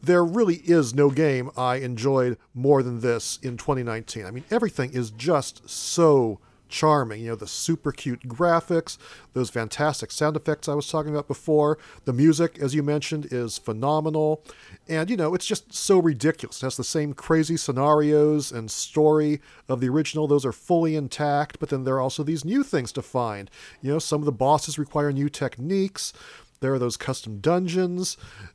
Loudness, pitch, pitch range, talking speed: -24 LUFS, 145 Hz, 125-155 Hz, 185 wpm